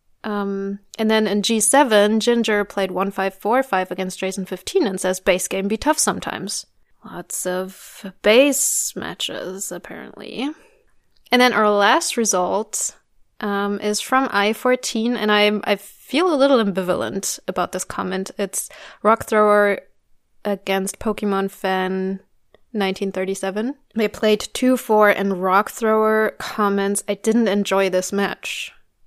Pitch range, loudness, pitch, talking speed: 195-220 Hz, -20 LUFS, 205 Hz, 135 wpm